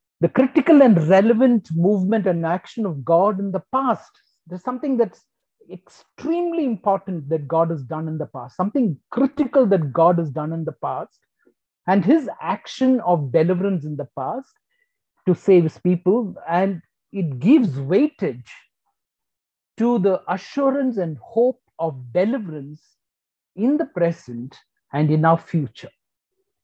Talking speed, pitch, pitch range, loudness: 140 wpm, 185 Hz, 165-250 Hz, -20 LUFS